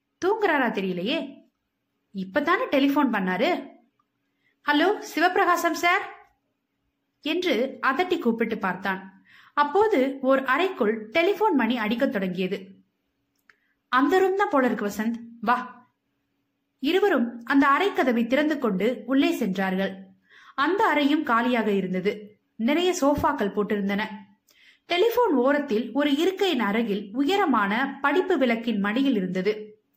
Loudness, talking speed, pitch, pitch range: -24 LUFS, 85 wpm, 265 Hz, 215-325 Hz